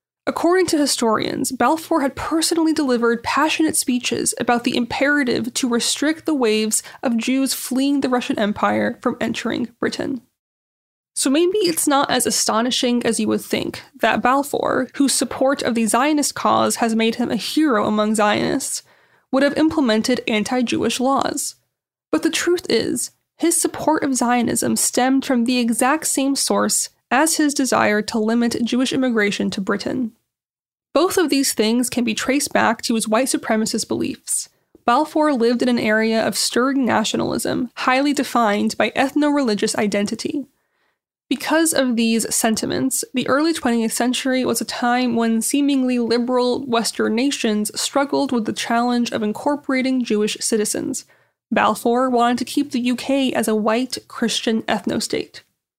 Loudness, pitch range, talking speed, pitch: -19 LUFS, 230-280 Hz, 150 wpm, 250 Hz